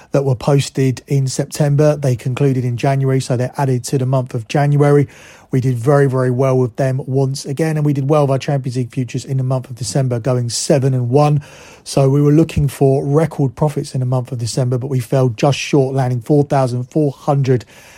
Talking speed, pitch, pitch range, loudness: 220 wpm, 135 Hz, 130-145 Hz, -16 LUFS